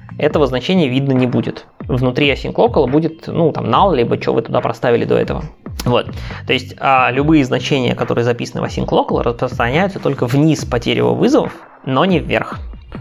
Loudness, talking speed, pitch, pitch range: -15 LUFS, 180 wpm, 140 Hz, 125-155 Hz